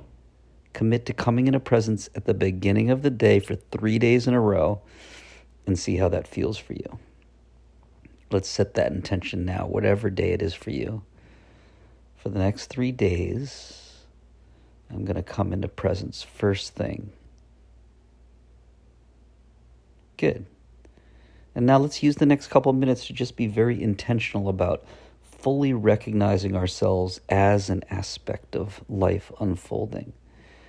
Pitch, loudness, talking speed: 100 Hz, -24 LUFS, 145 wpm